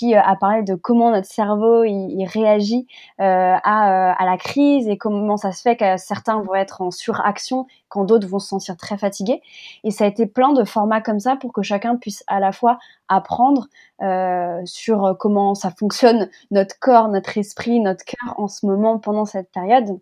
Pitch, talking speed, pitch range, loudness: 210 Hz, 200 wpm, 195-230 Hz, -18 LUFS